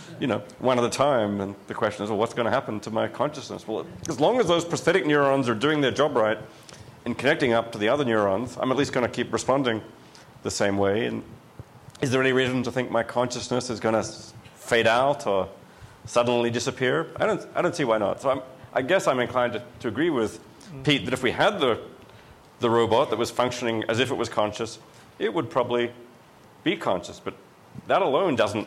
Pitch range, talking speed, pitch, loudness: 110-130 Hz, 220 wpm, 120 Hz, -25 LUFS